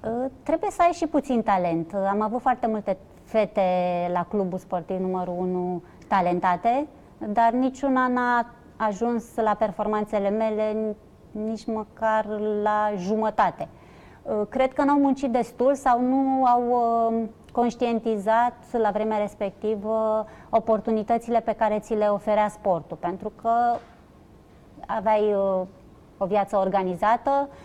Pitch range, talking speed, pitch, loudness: 200-240 Hz, 115 wpm, 220 Hz, -24 LUFS